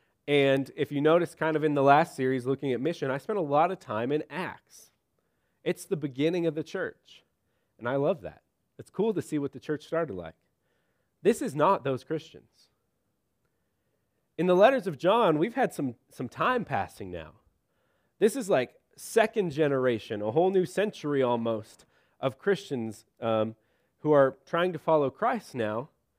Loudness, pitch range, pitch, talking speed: -28 LUFS, 130-170 Hz, 150 Hz, 175 wpm